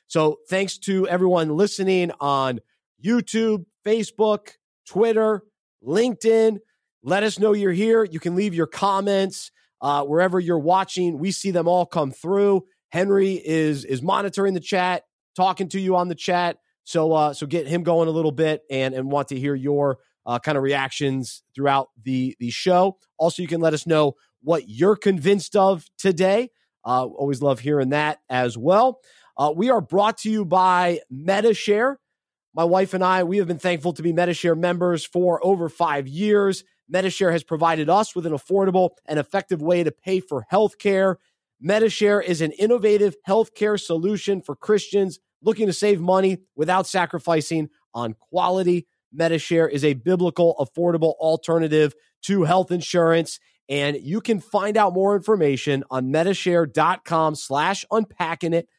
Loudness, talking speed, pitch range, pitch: -21 LUFS, 165 wpm, 155-195 Hz, 180 Hz